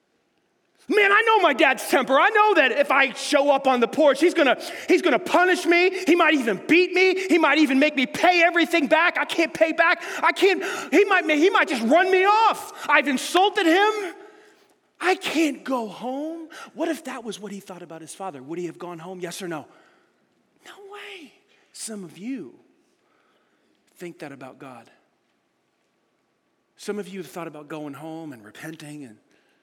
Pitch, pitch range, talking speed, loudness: 315 Hz, 215-365 Hz, 190 wpm, -20 LUFS